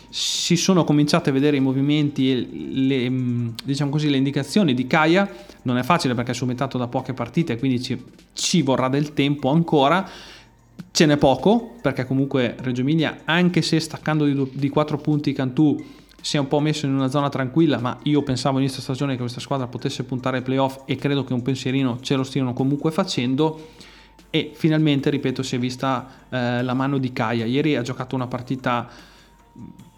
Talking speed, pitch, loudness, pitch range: 190 wpm, 135 Hz, -21 LUFS, 130-150 Hz